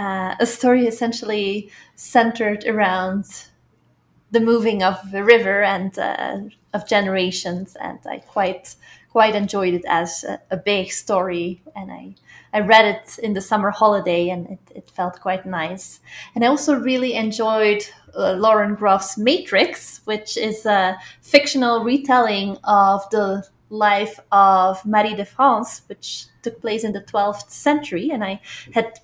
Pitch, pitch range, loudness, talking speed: 210 Hz, 195-225 Hz, -19 LUFS, 150 wpm